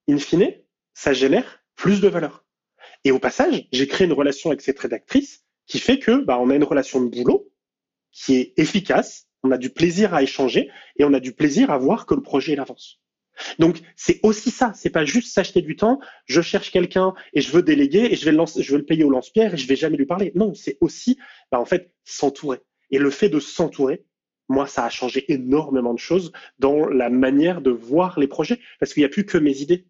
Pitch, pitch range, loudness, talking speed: 160 Hz, 135-205 Hz, -20 LUFS, 235 wpm